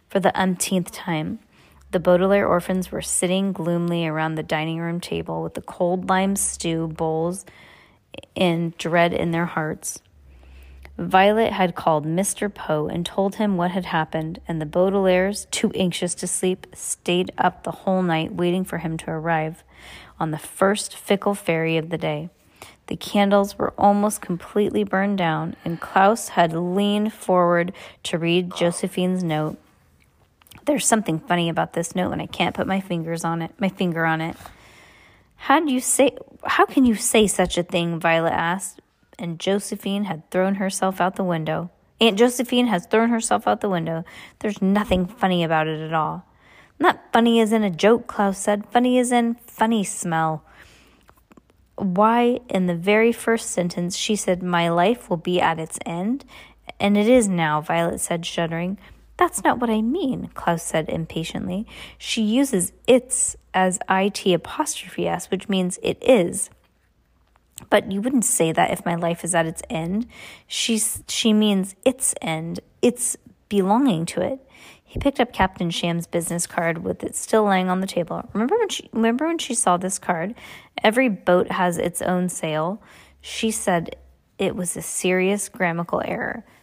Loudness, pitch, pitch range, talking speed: -22 LUFS, 185 Hz, 170-210 Hz, 170 wpm